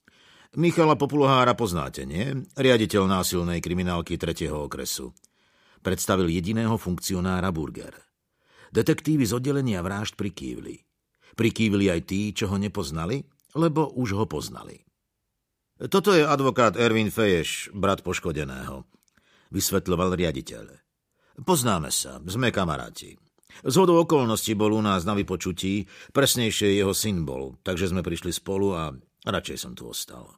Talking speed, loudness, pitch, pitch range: 120 wpm, -25 LUFS, 100 Hz, 90-120 Hz